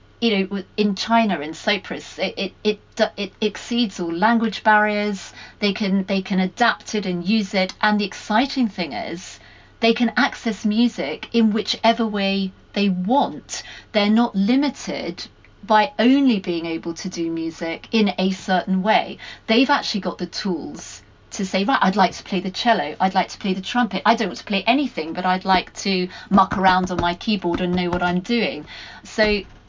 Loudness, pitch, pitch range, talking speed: -21 LUFS, 205 Hz, 185-225 Hz, 185 wpm